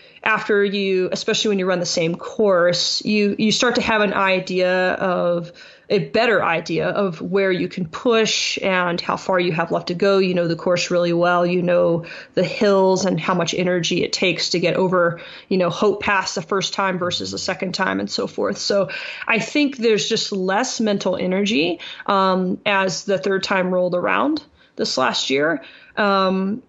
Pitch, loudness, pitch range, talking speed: 190 Hz, -19 LUFS, 180-205 Hz, 190 wpm